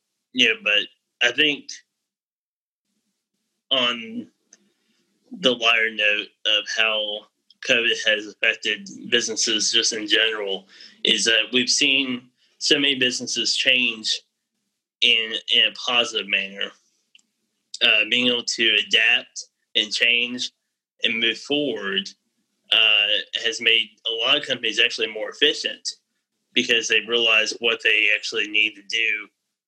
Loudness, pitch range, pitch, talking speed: -19 LUFS, 110-145 Hz, 120 Hz, 120 wpm